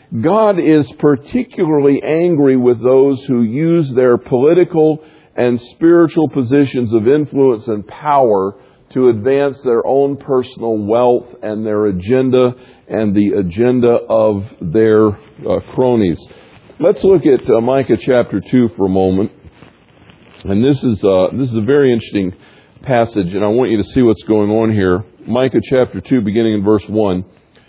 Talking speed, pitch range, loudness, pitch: 155 wpm, 105-135 Hz, -13 LUFS, 120 Hz